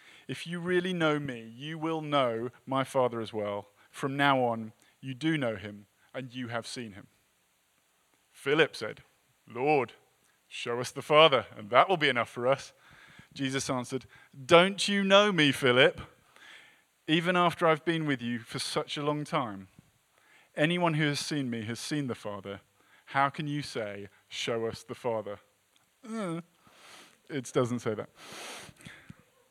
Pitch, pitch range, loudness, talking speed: 135 Hz, 115-155 Hz, -29 LUFS, 155 wpm